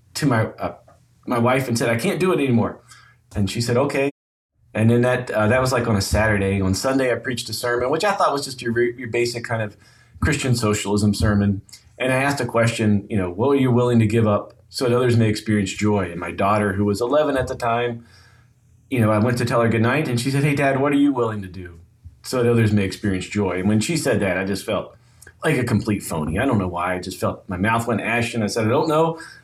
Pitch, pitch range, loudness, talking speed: 115 Hz, 105-125 Hz, -20 LUFS, 265 wpm